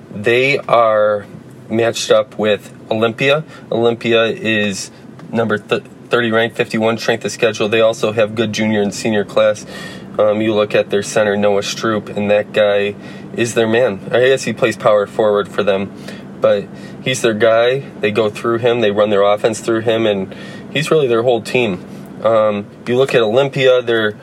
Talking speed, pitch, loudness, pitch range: 180 wpm, 110 Hz, -15 LUFS, 105-115 Hz